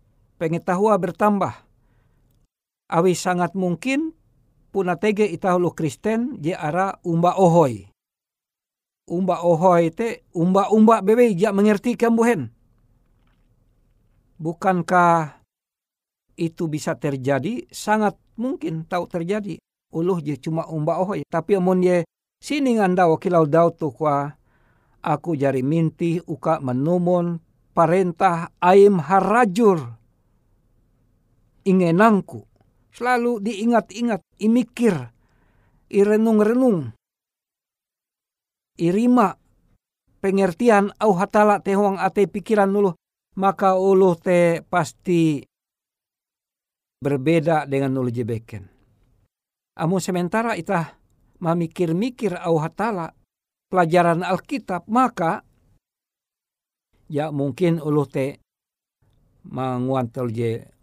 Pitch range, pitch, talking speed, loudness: 140-200 Hz, 170 Hz, 85 wpm, -20 LUFS